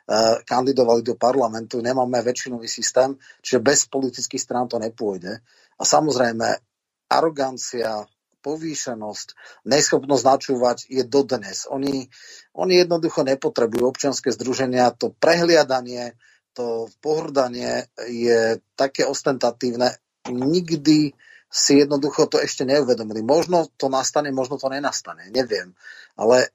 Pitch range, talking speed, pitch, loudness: 120-140 Hz, 105 wpm, 130 Hz, -21 LUFS